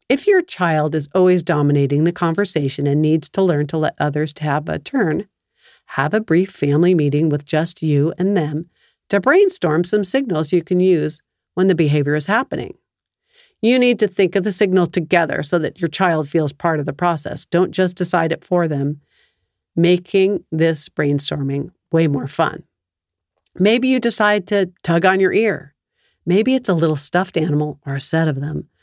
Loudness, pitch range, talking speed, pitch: -18 LUFS, 150-190 Hz, 185 wpm, 170 Hz